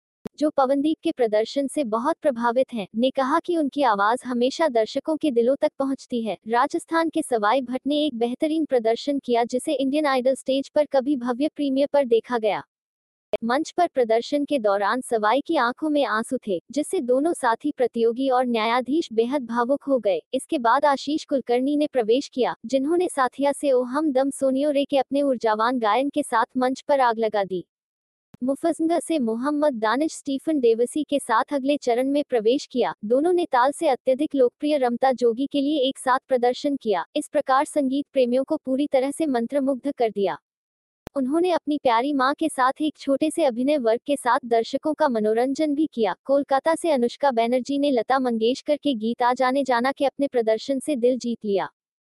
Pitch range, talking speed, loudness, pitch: 240-290 Hz, 185 wpm, -23 LUFS, 270 Hz